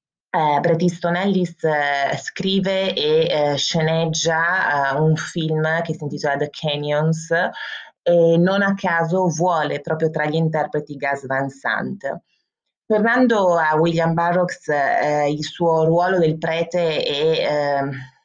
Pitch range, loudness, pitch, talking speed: 150-180 Hz, -19 LUFS, 160 Hz, 135 wpm